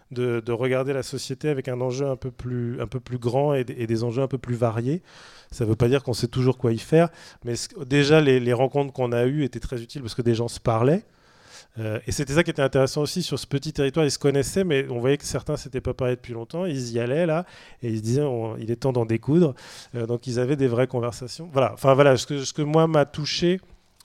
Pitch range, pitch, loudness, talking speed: 120-145 Hz, 130 Hz, -24 LUFS, 270 wpm